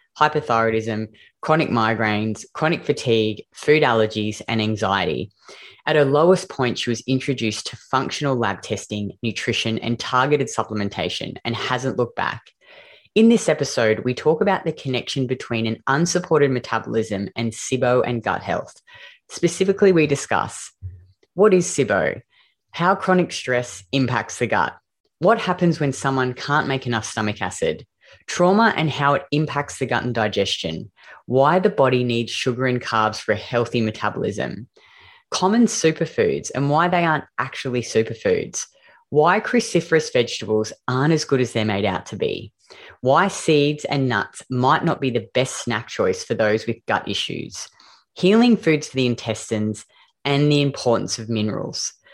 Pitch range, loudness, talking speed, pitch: 110-155 Hz, -21 LUFS, 150 wpm, 130 Hz